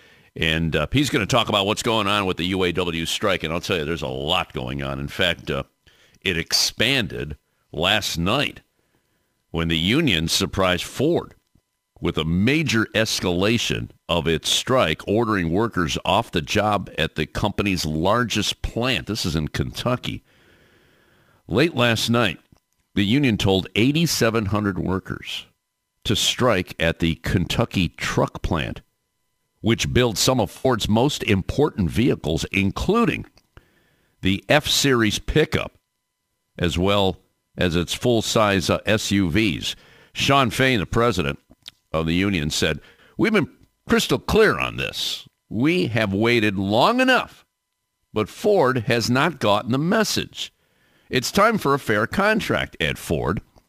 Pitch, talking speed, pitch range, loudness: 100 Hz, 140 wpm, 85-115 Hz, -21 LUFS